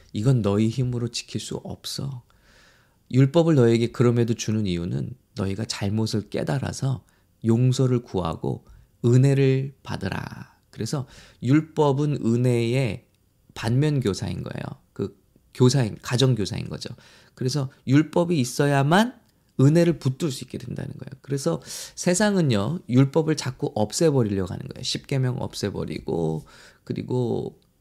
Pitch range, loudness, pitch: 110-140 Hz, -24 LUFS, 125 Hz